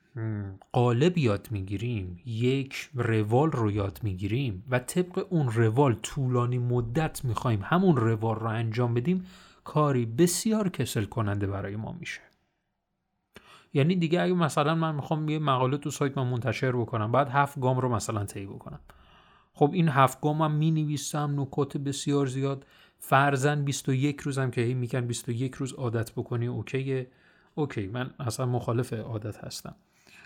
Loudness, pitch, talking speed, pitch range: -28 LUFS, 130 Hz, 145 wpm, 115-150 Hz